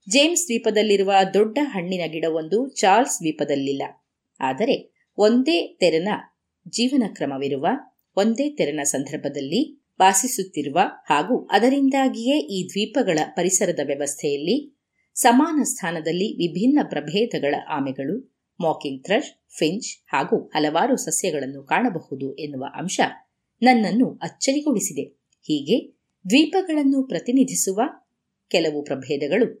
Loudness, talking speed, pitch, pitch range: -22 LUFS, 85 wpm, 195 Hz, 155-255 Hz